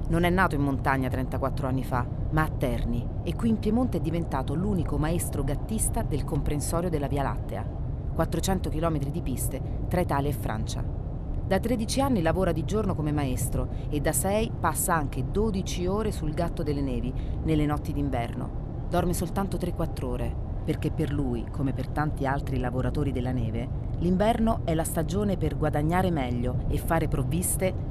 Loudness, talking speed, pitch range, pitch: -28 LUFS, 170 wpm, 120-150 Hz, 135 Hz